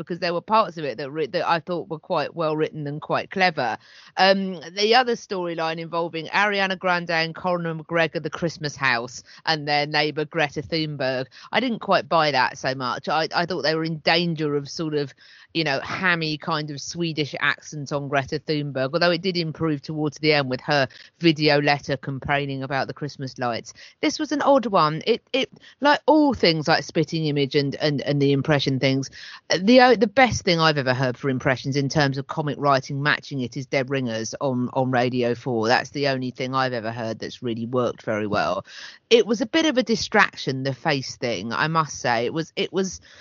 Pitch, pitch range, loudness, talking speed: 150 Hz, 135-170 Hz, -23 LUFS, 210 wpm